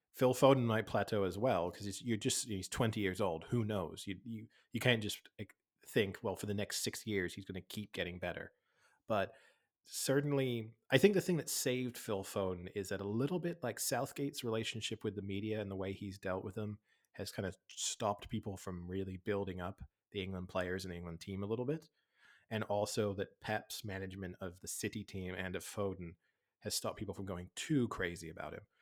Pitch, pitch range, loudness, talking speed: 105 Hz, 95-120 Hz, -38 LUFS, 205 wpm